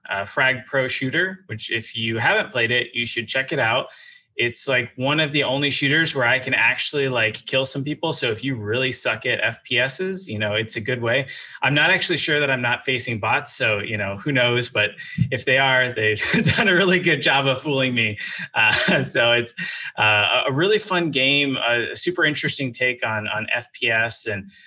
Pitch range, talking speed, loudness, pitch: 115-145 Hz, 210 wpm, -20 LUFS, 130 Hz